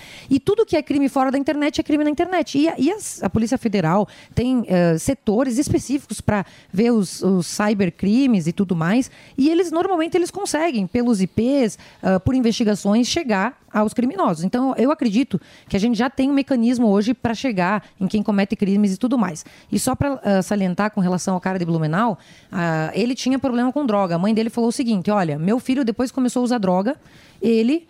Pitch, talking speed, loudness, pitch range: 230 Hz, 205 wpm, -20 LUFS, 200-270 Hz